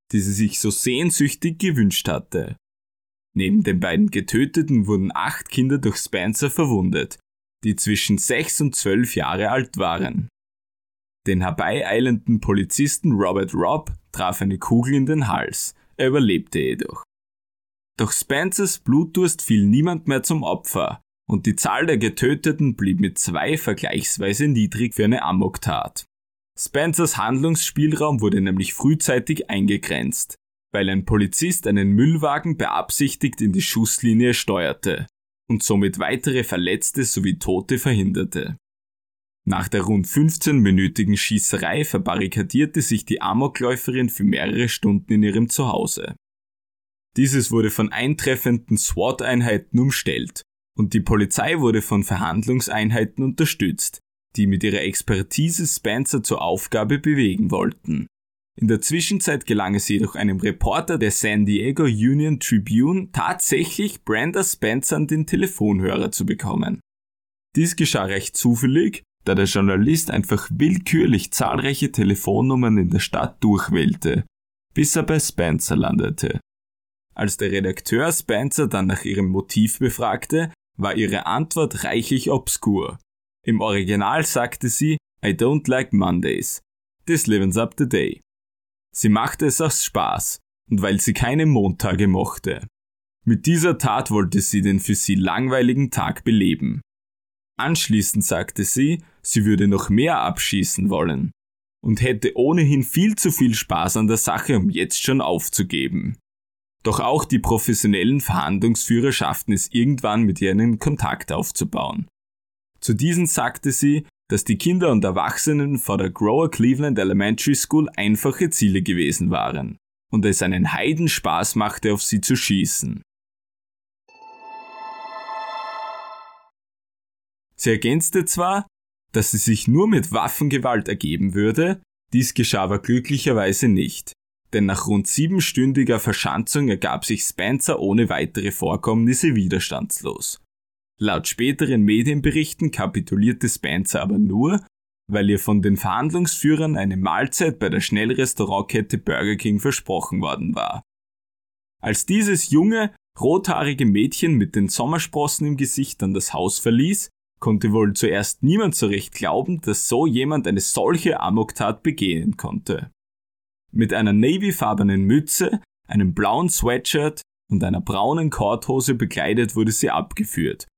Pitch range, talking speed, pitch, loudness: 100-150 Hz, 130 wpm, 115 Hz, -20 LUFS